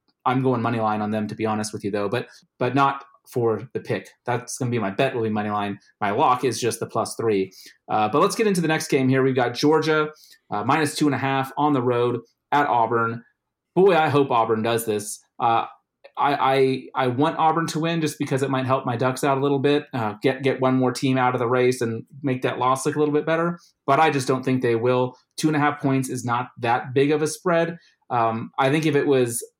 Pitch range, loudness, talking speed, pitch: 120-145 Hz, -22 LUFS, 255 wpm, 130 Hz